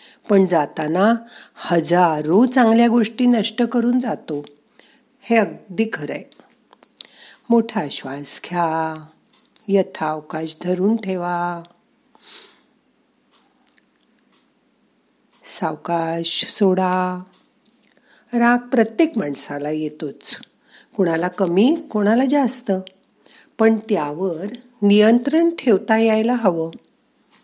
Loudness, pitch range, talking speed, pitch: -19 LUFS, 175-240 Hz, 70 wpm, 210 Hz